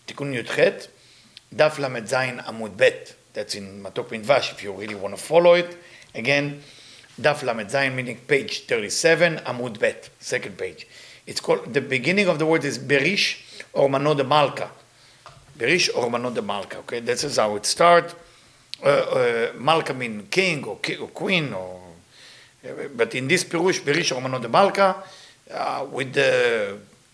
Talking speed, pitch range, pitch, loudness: 140 wpm, 130-185 Hz, 150 Hz, -22 LUFS